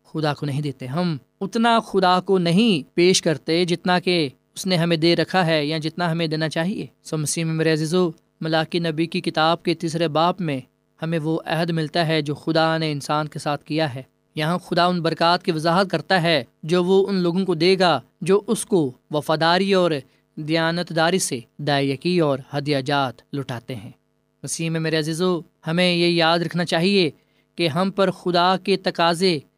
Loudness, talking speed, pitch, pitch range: -21 LUFS, 185 wpm, 165 Hz, 155-180 Hz